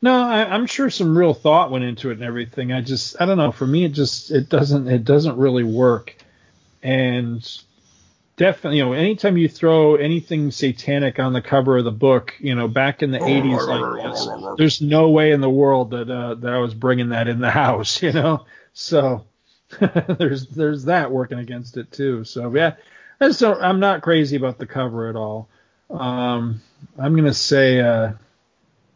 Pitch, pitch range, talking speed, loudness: 135 Hz, 125-155 Hz, 190 wpm, -18 LUFS